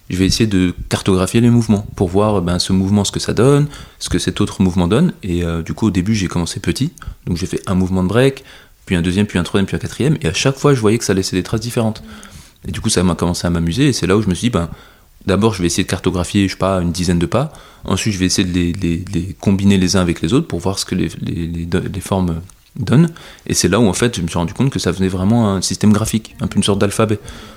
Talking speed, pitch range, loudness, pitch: 295 wpm, 90-110 Hz, -16 LUFS, 95 Hz